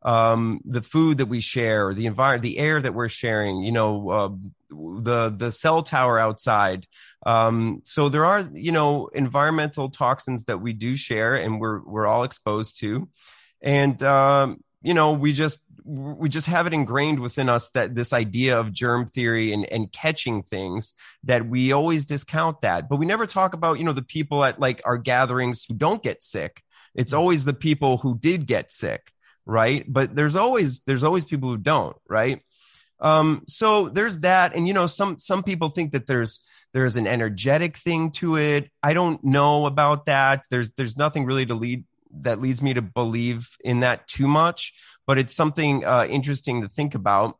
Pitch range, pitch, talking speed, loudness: 120-155 Hz, 135 Hz, 190 wpm, -22 LUFS